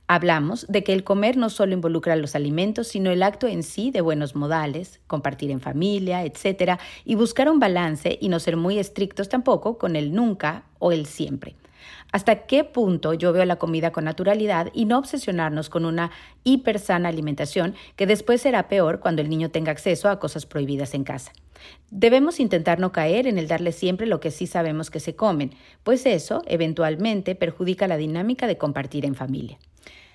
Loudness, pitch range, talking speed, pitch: -23 LUFS, 160-205 Hz, 185 wpm, 175 Hz